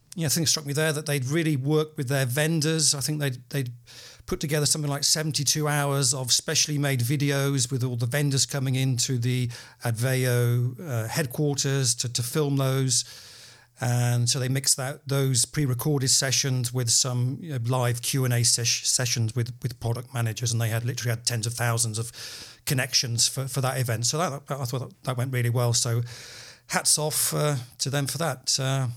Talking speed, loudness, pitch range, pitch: 195 wpm, -25 LUFS, 120-145 Hz, 130 Hz